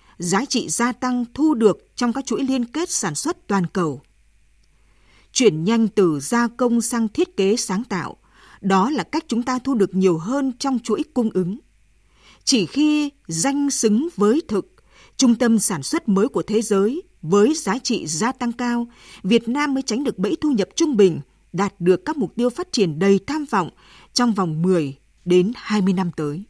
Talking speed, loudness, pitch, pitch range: 190 wpm, -20 LUFS, 220 Hz, 190-255 Hz